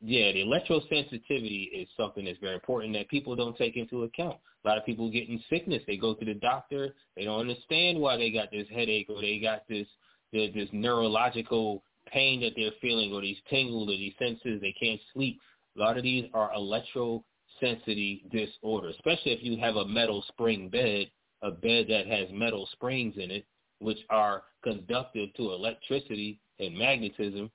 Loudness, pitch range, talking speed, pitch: -30 LUFS, 105-120 Hz, 180 wpm, 110 Hz